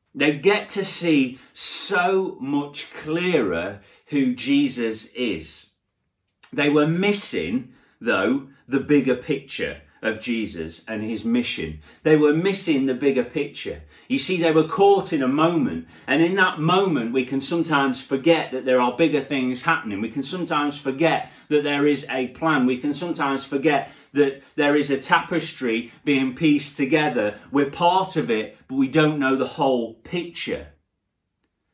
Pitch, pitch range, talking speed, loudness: 145 Hz, 130-165 Hz, 155 wpm, -22 LUFS